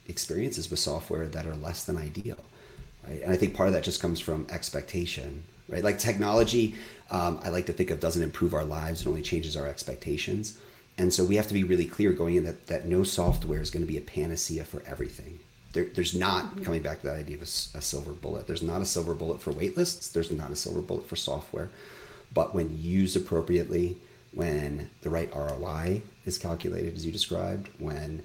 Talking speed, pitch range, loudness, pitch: 215 wpm, 80-90 Hz, -30 LUFS, 85 Hz